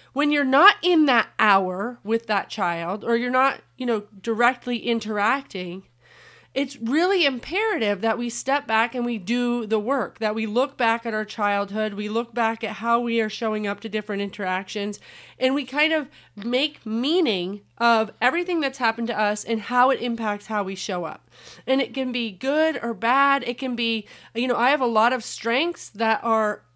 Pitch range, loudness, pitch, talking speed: 215-260 Hz, -23 LUFS, 230 Hz, 195 wpm